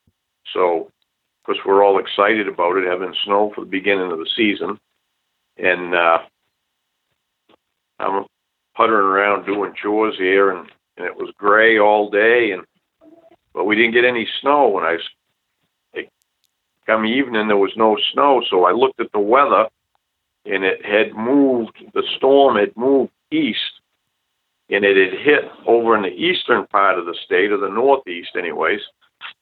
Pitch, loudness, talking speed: 110 Hz, -17 LUFS, 160 wpm